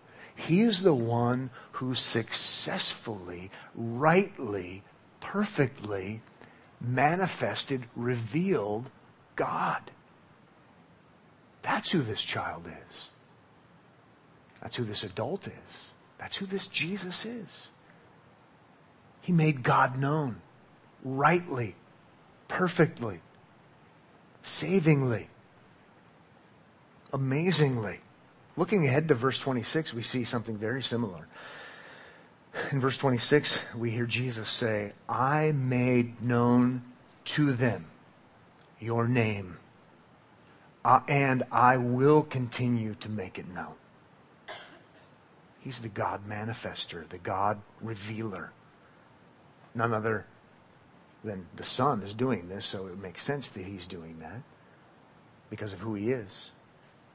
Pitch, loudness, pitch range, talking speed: 120 Hz, -29 LUFS, 110-145 Hz, 100 wpm